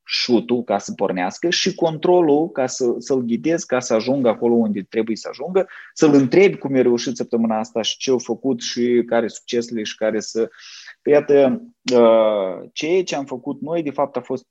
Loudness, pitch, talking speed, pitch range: -19 LUFS, 125 Hz, 190 wpm, 115-145 Hz